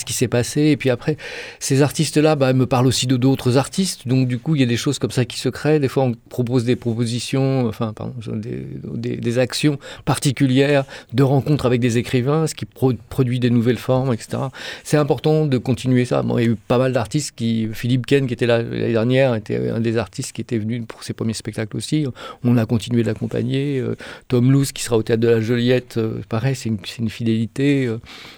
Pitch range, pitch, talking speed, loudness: 115-135 Hz, 125 Hz, 230 wpm, -20 LUFS